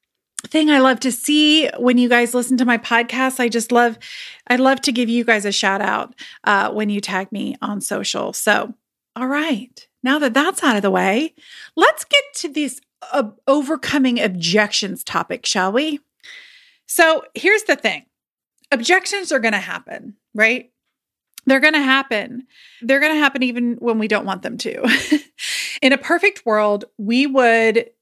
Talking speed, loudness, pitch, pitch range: 175 wpm, -17 LUFS, 255 Hz, 230-295 Hz